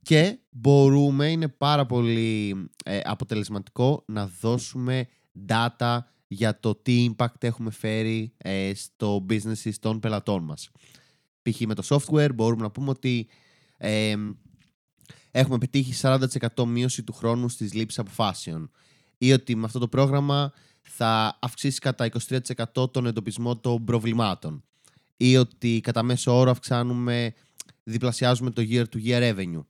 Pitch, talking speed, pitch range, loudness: 120 Hz, 130 wpm, 110-130 Hz, -25 LUFS